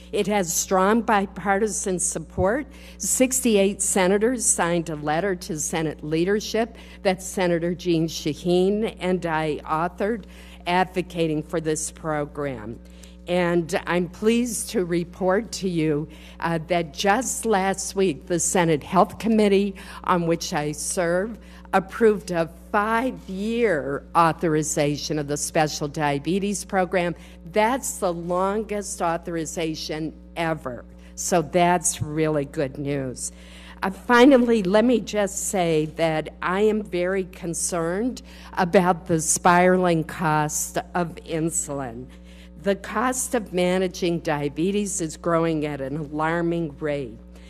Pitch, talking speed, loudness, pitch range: 175 Hz, 115 wpm, -23 LUFS, 155-195 Hz